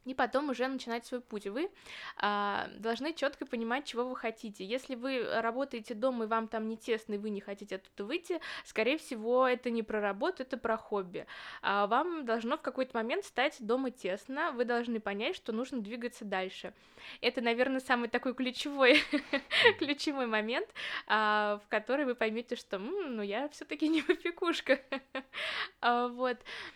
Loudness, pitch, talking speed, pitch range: -33 LUFS, 245 Hz, 160 wpm, 225-275 Hz